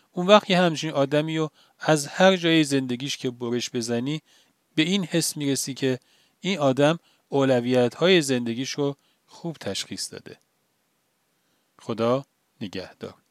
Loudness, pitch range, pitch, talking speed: -23 LUFS, 125-165 Hz, 145 Hz, 130 wpm